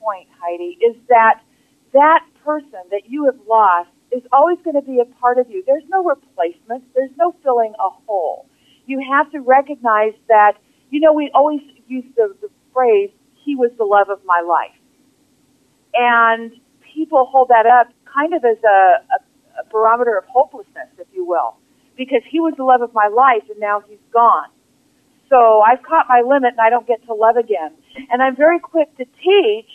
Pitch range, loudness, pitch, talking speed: 225-290 Hz, -15 LUFS, 260 Hz, 190 wpm